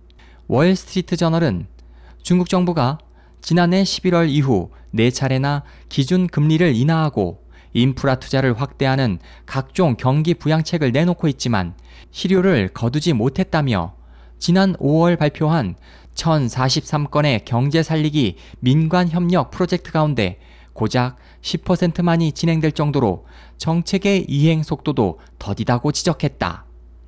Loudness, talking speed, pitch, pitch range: -19 LUFS, 255 characters per minute, 145 Hz, 115-170 Hz